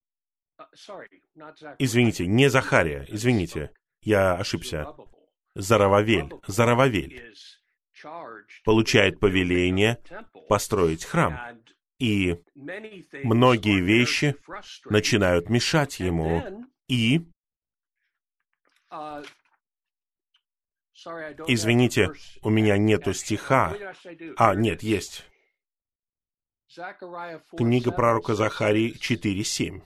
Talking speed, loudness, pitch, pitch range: 60 wpm, -23 LUFS, 115 Hz, 105-140 Hz